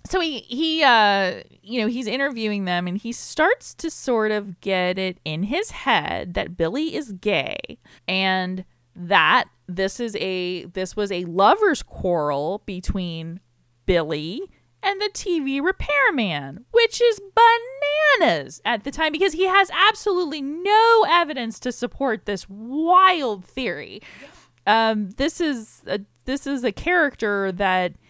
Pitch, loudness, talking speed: 235 Hz, -21 LUFS, 140 wpm